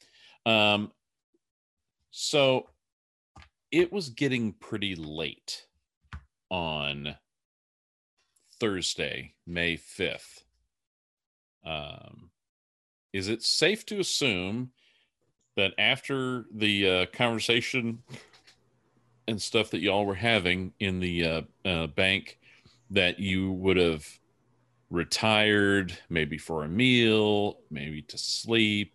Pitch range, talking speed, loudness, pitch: 85-120 Hz, 95 wpm, -27 LUFS, 105 Hz